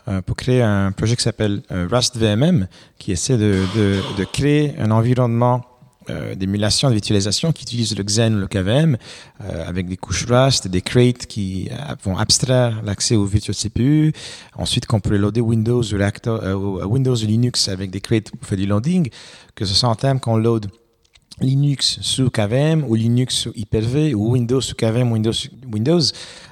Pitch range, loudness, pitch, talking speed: 100-125 Hz, -18 LUFS, 115 Hz, 180 wpm